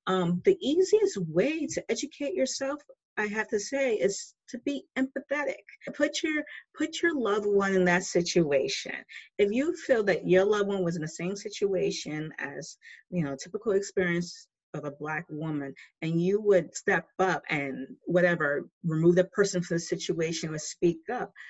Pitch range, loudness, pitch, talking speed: 170-275 Hz, -28 LUFS, 195 Hz, 170 wpm